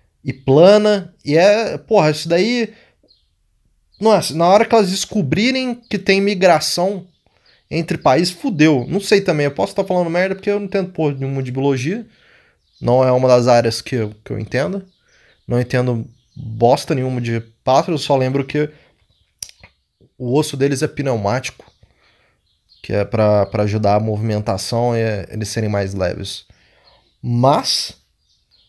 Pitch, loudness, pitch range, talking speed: 135 Hz, -17 LUFS, 110-180 Hz, 155 wpm